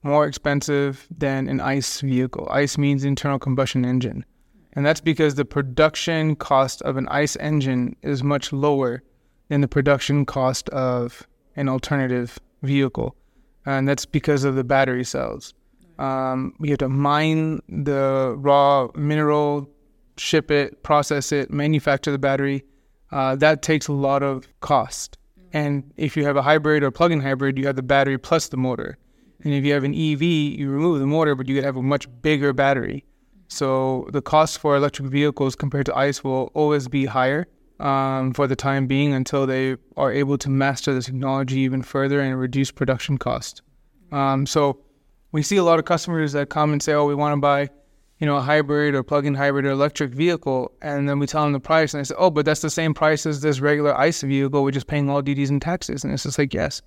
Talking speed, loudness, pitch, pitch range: 200 wpm, -21 LUFS, 140 Hz, 135-150 Hz